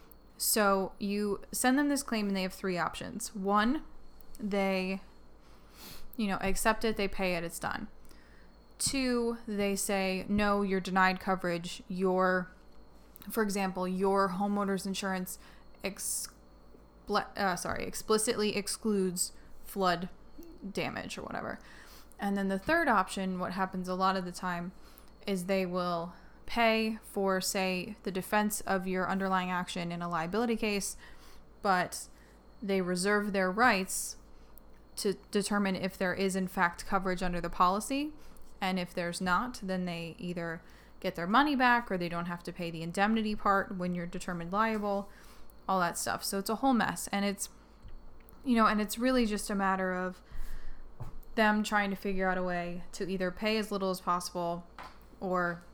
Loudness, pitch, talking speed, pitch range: -32 LUFS, 195 Hz, 155 wpm, 185-210 Hz